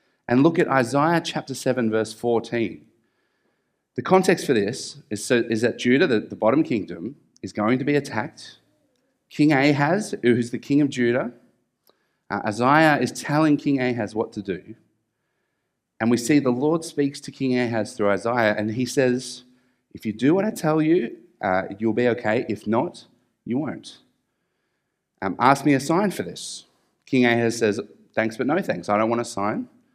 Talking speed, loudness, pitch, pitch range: 180 wpm, -22 LUFS, 125 Hz, 115-145 Hz